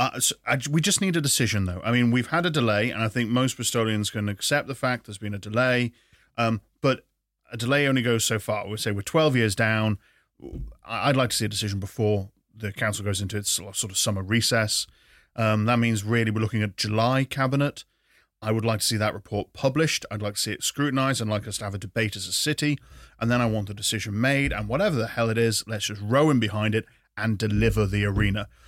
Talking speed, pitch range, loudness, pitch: 240 wpm, 105-125 Hz, -25 LUFS, 110 Hz